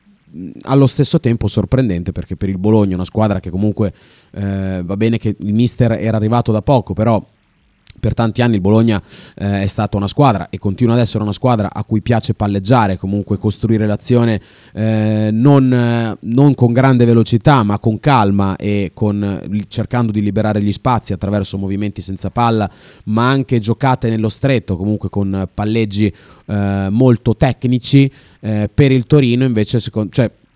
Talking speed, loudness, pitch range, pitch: 165 wpm, -15 LUFS, 100-120 Hz, 110 Hz